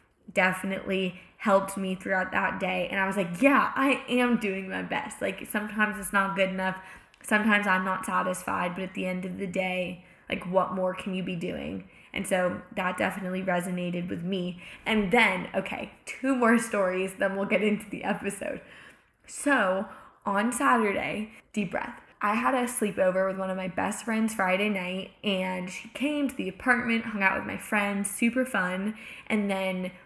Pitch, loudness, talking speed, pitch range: 195 Hz, -28 LUFS, 180 wpm, 185-215 Hz